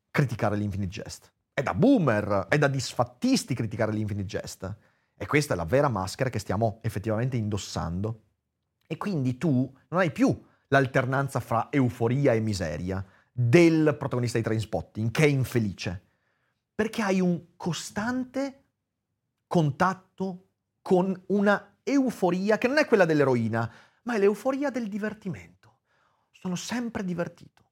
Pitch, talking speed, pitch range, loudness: 135 Hz, 130 wpm, 110-185 Hz, -27 LUFS